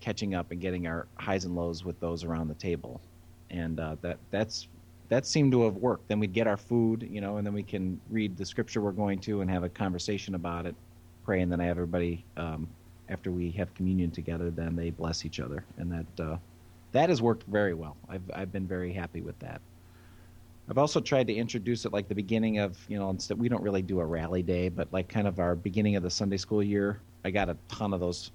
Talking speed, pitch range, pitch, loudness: 240 wpm, 85-105 Hz, 90 Hz, -31 LUFS